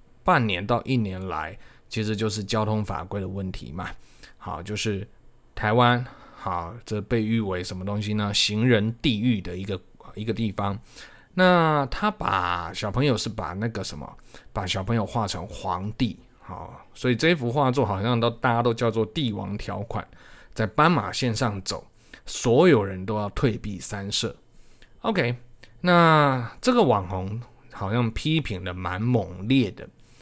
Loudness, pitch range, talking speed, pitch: -25 LUFS, 100-120 Hz, 225 characters per minute, 110 Hz